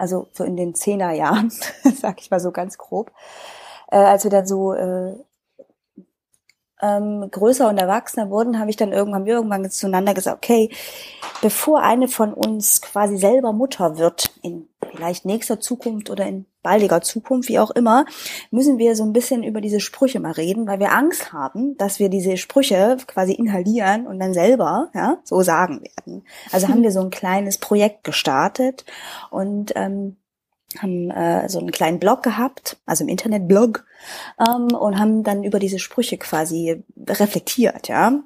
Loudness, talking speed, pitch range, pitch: -19 LUFS, 170 wpm, 190-240 Hz, 210 Hz